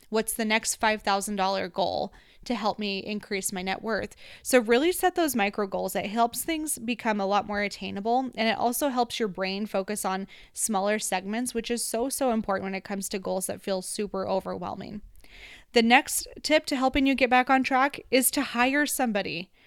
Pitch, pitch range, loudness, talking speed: 220 Hz, 195-250 Hz, -26 LUFS, 195 wpm